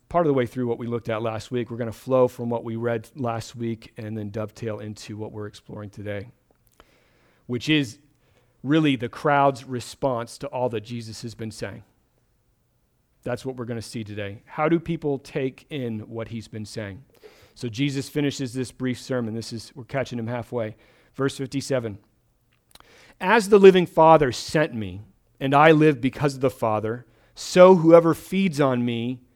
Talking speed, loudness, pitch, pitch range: 185 wpm, -23 LUFS, 125 Hz, 115-140 Hz